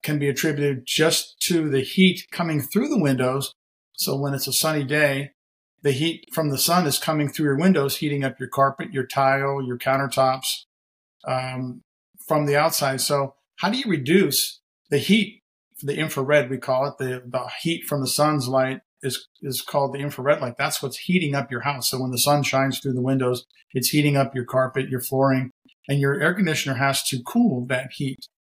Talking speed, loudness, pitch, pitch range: 200 wpm, -22 LUFS, 140 Hz, 130-155 Hz